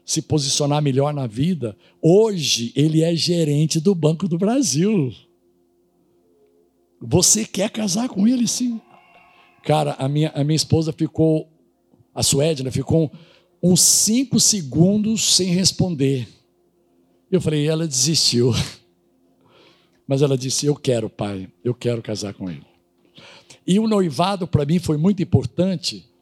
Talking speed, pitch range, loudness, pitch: 135 wpm, 120-180 Hz, -19 LUFS, 150 Hz